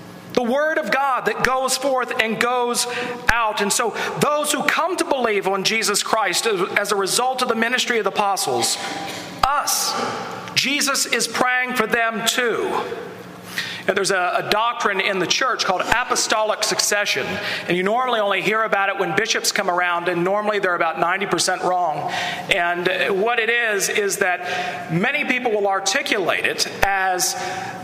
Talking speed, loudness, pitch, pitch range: 165 wpm, -19 LUFS, 220 Hz, 195-250 Hz